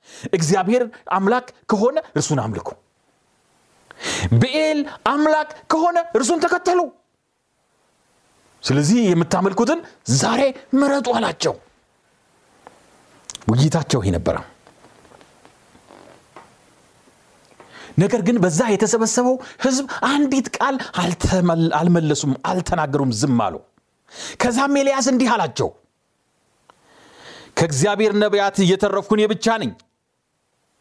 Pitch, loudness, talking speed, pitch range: 220 Hz, -19 LUFS, 75 wpm, 175-270 Hz